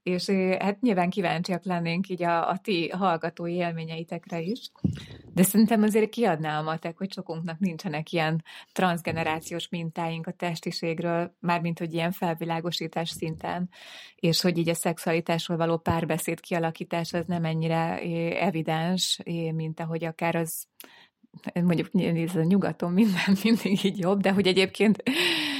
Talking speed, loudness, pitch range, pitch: 135 wpm, -27 LUFS, 165-190 Hz, 175 Hz